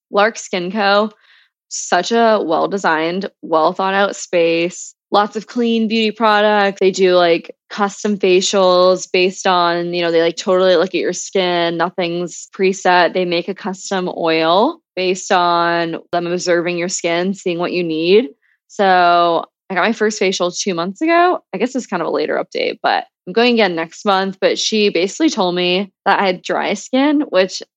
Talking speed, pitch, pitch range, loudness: 180 wpm, 190 Hz, 175-210 Hz, -16 LUFS